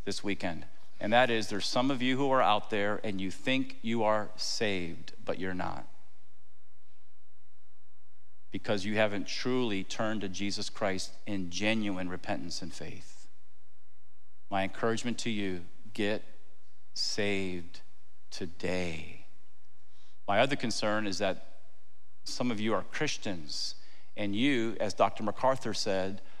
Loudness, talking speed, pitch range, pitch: -32 LUFS, 130 wpm, 90-110 Hz, 100 Hz